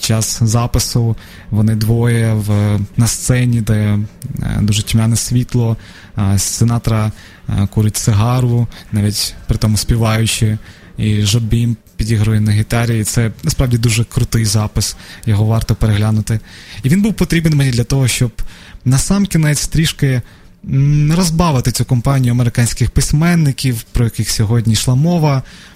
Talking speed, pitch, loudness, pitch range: 135 wpm, 115 Hz, -15 LUFS, 105-125 Hz